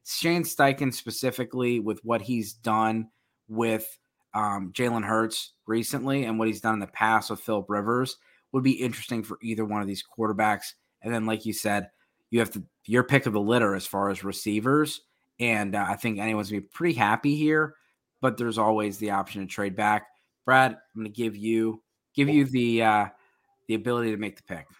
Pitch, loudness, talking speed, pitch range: 110 Hz, -26 LUFS, 200 wpm, 105-125 Hz